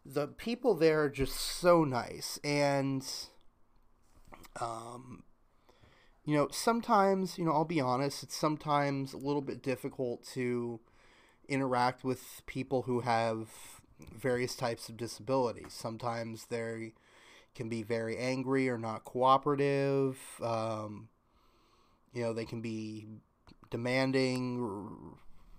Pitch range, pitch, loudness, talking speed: 115-140 Hz, 125 Hz, -33 LUFS, 115 wpm